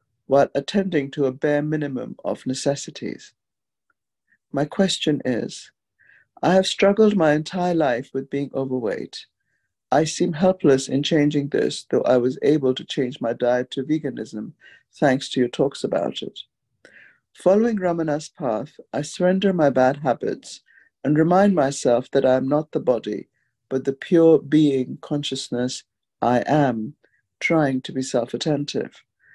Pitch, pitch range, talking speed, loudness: 145 Hz, 130-160 Hz, 145 wpm, -21 LUFS